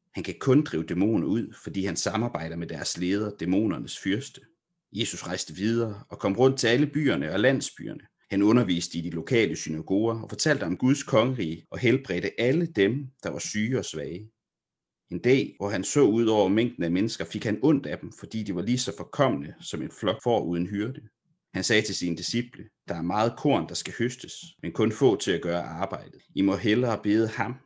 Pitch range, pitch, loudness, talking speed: 95-125 Hz, 110 Hz, -26 LUFS, 210 wpm